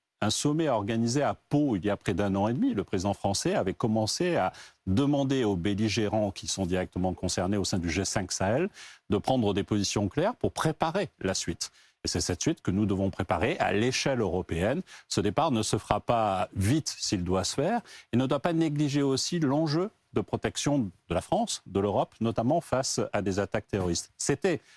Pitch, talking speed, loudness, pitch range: 105 Hz, 200 wpm, -28 LUFS, 100-130 Hz